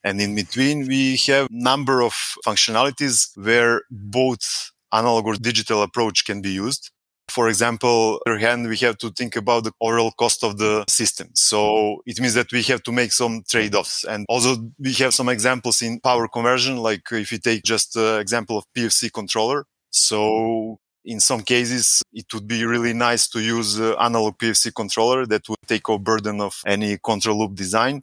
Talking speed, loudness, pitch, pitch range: 190 wpm, -19 LUFS, 115 Hz, 110-120 Hz